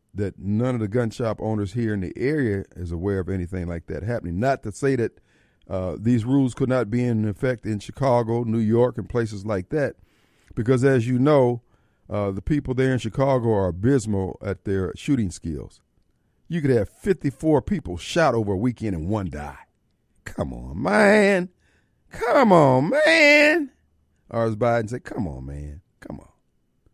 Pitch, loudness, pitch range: 115 Hz, -22 LUFS, 95-130 Hz